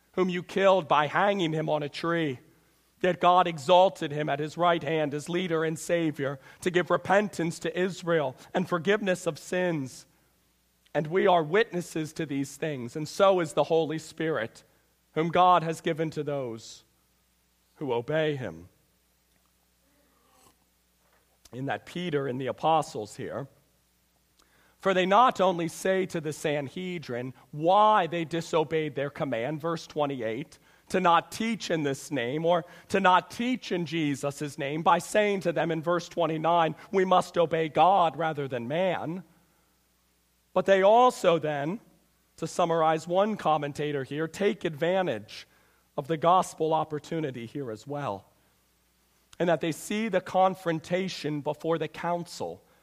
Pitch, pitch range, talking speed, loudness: 160 Hz, 145-180 Hz, 145 wpm, -27 LUFS